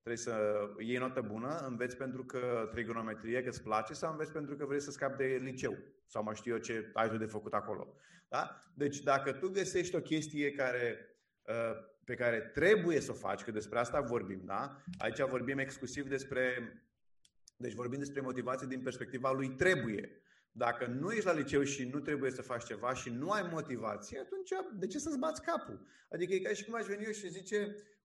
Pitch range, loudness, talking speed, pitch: 120-150 Hz, -37 LUFS, 195 wpm, 130 Hz